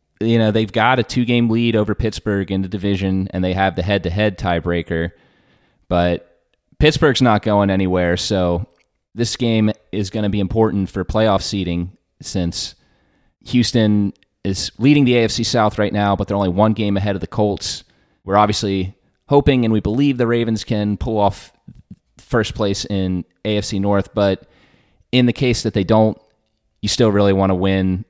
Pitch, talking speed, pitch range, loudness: 105 Hz, 175 wpm, 95-110 Hz, -18 LUFS